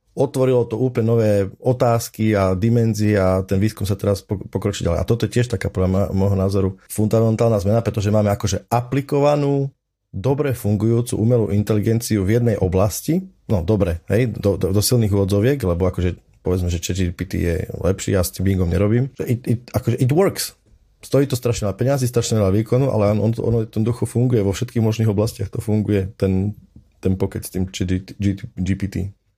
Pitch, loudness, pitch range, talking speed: 105 Hz, -20 LUFS, 95-120 Hz, 180 wpm